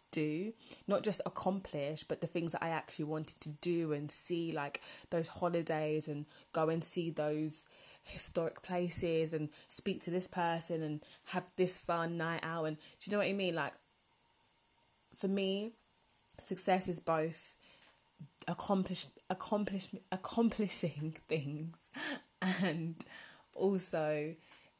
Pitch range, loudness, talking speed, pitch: 155-185 Hz, -33 LUFS, 130 wpm, 170 Hz